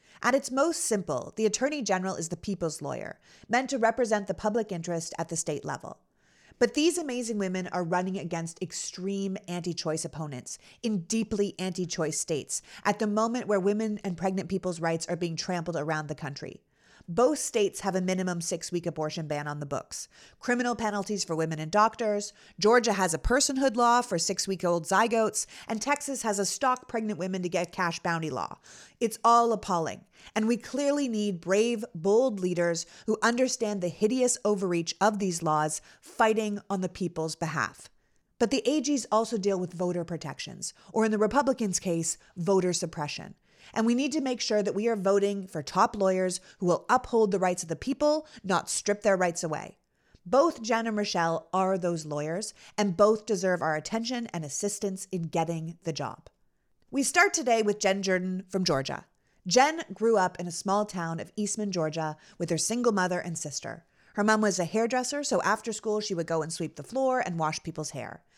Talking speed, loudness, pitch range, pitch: 190 wpm, -28 LUFS, 170-225 Hz, 195 Hz